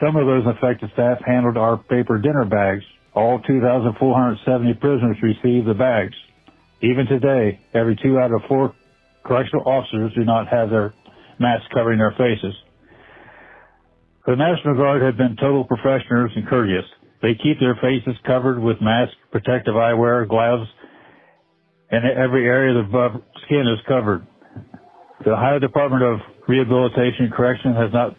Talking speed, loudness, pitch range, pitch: 150 wpm, -19 LUFS, 115-130 Hz, 125 Hz